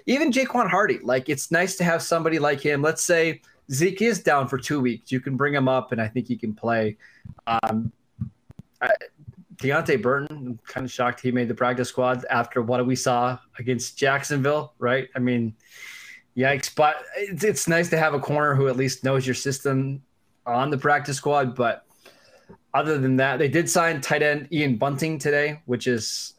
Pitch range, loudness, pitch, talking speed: 125-150 Hz, -23 LUFS, 135 Hz, 190 wpm